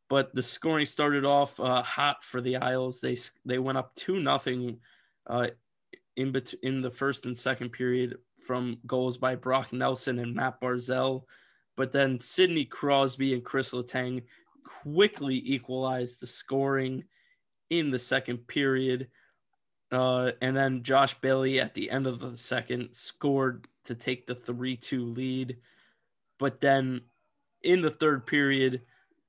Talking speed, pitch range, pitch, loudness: 145 wpm, 125-135 Hz, 130 Hz, -29 LUFS